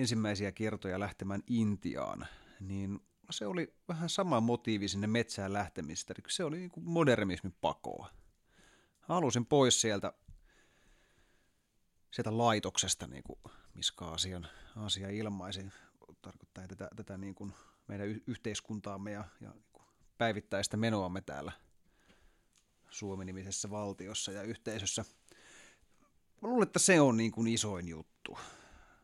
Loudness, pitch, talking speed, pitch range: -35 LUFS, 105 Hz, 120 wpm, 95-115 Hz